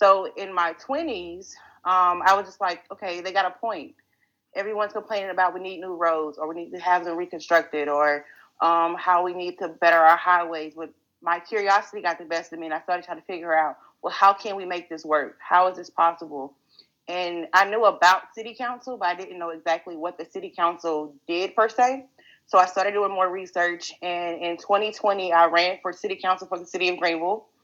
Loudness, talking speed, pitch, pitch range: -24 LUFS, 215 wpm, 180 Hz, 170-195 Hz